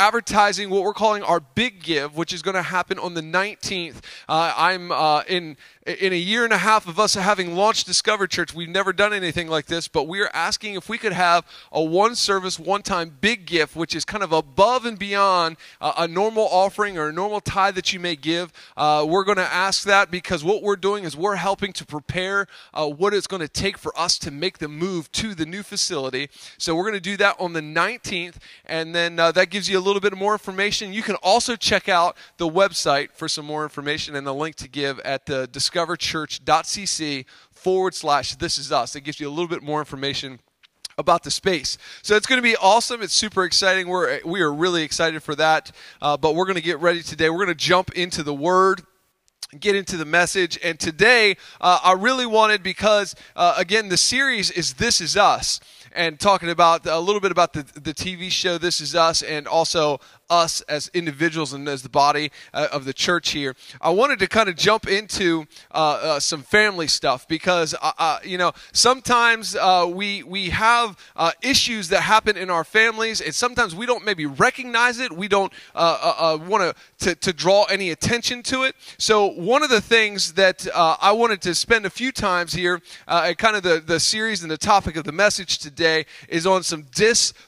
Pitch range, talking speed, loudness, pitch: 160-205 Hz, 215 wpm, -20 LUFS, 180 Hz